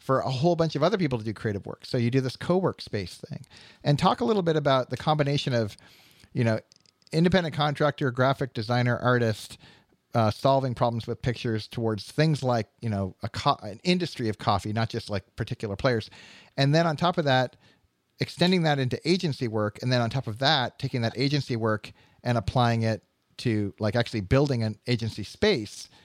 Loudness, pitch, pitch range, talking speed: -26 LUFS, 125 Hz, 110-145 Hz, 200 wpm